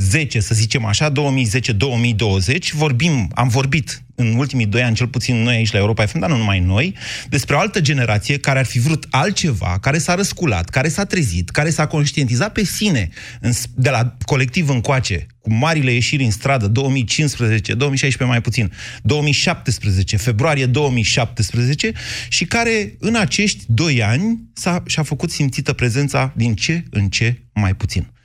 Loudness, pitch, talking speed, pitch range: -17 LUFS, 130 Hz, 160 wpm, 115-150 Hz